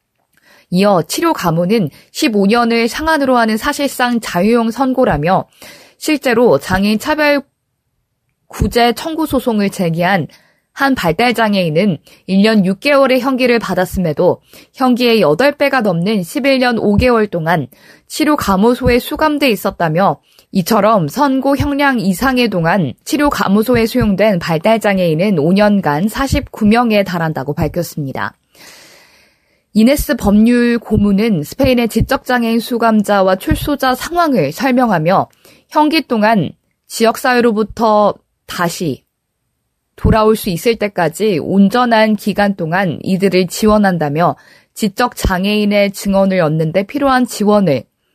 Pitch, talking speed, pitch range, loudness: 220 Hz, 265 characters per minute, 190-250 Hz, -13 LUFS